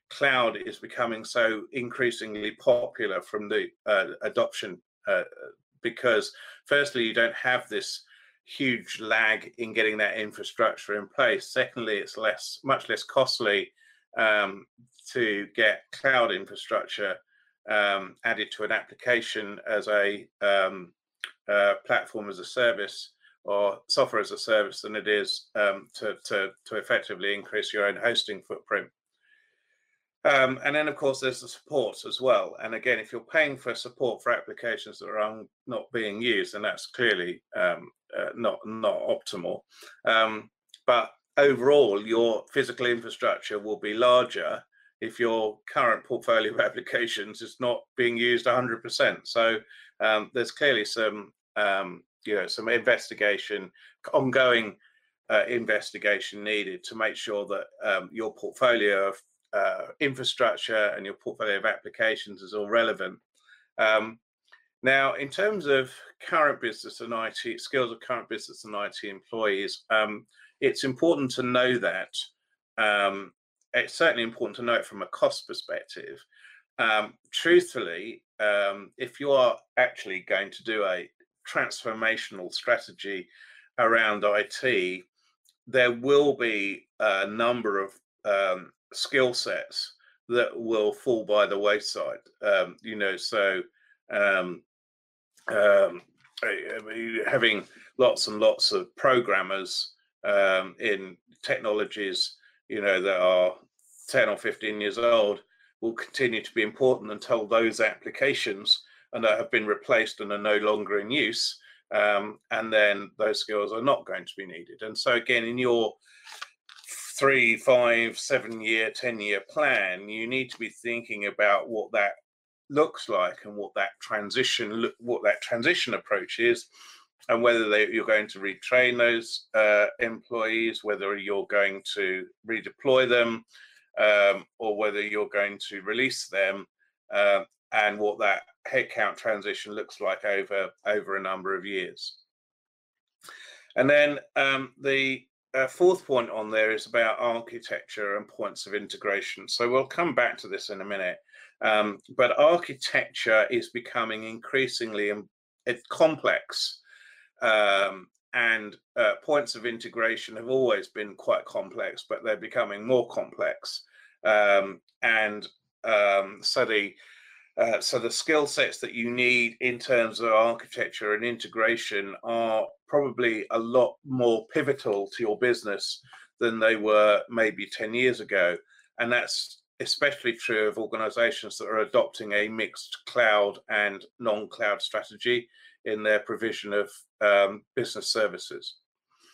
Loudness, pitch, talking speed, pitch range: -26 LUFS, 115 Hz, 140 wpm, 105-135 Hz